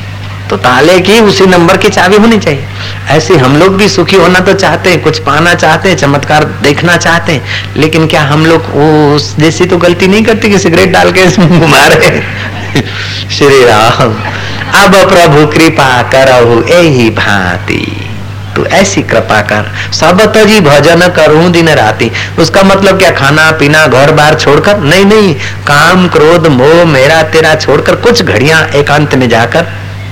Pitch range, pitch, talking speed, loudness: 110-175 Hz, 150 Hz, 160 wpm, -5 LUFS